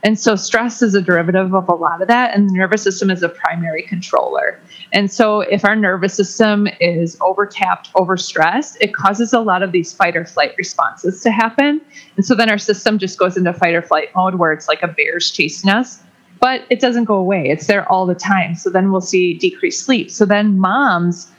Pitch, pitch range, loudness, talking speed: 195 Hz, 180-220 Hz, -15 LUFS, 220 wpm